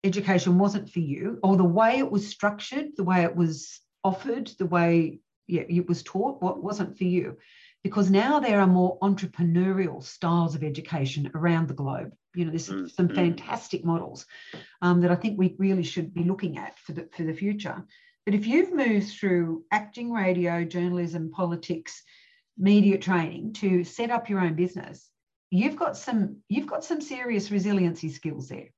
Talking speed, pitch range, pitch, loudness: 175 wpm, 170-210 Hz, 185 Hz, -26 LUFS